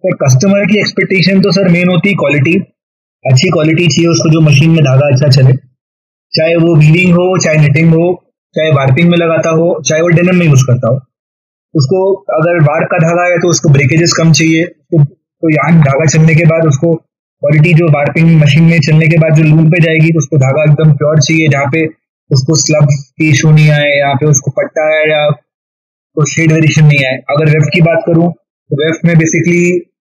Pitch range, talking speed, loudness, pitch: 150-170 Hz, 210 wpm, -8 LUFS, 160 Hz